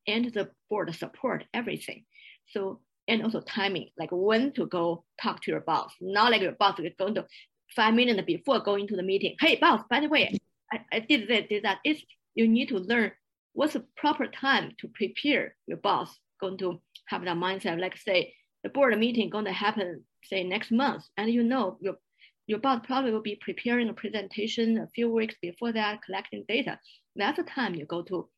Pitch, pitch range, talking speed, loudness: 215 Hz, 195-240 Hz, 205 wpm, -28 LUFS